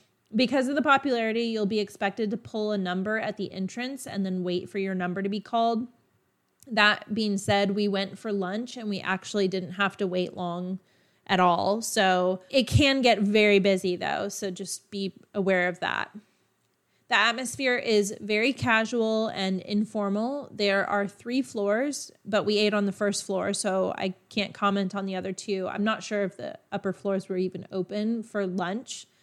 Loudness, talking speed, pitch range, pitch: -27 LUFS, 185 wpm, 190-220 Hz, 205 Hz